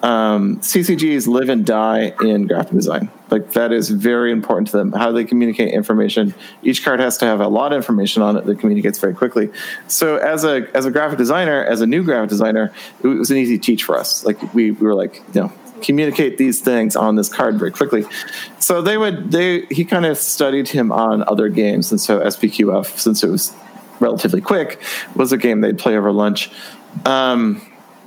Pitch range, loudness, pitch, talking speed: 110-155 Hz, -16 LUFS, 120 Hz, 205 wpm